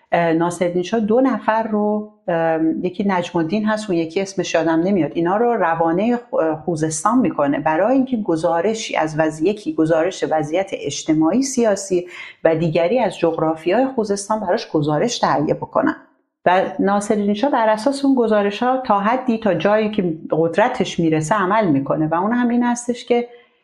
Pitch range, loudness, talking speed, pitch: 170-235 Hz, -18 LUFS, 155 wpm, 205 Hz